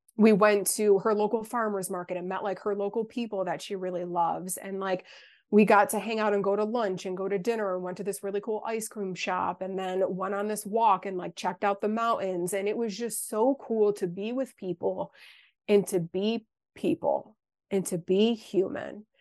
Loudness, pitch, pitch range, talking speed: -28 LUFS, 200 Hz, 190-220 Hz, 220 wpm